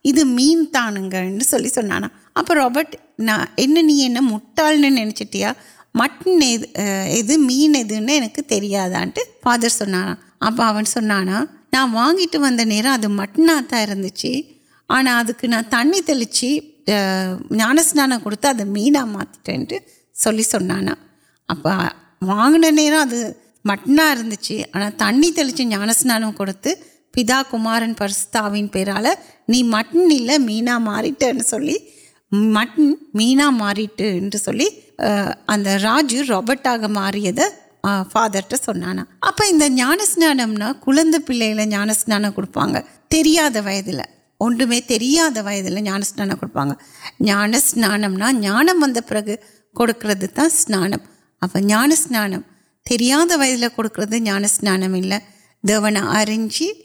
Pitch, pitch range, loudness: 235 Hz, 205-290 Hz, -17 LUFS